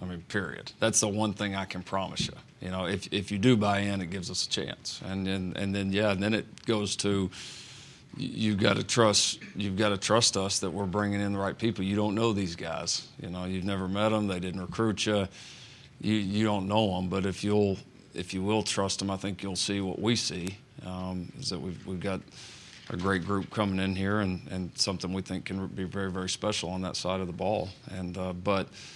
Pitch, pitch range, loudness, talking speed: 100 Hz, 95-105 Hz, -30 LUFS, 240 wpm